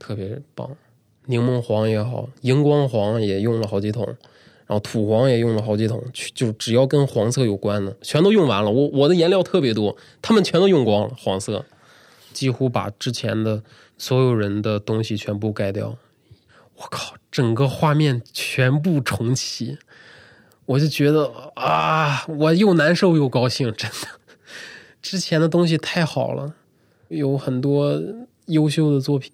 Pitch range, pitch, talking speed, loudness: 110-145 Hz, 125 Hz, 235 characters per minute, -20 LUFS